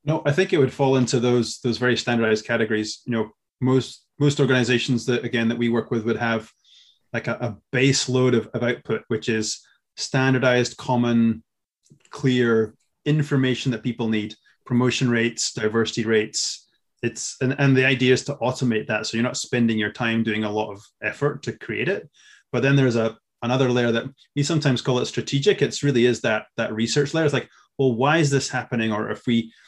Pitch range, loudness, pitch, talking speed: 115-130 Hz, -22 LUFS, 120 Hz, 200 wpm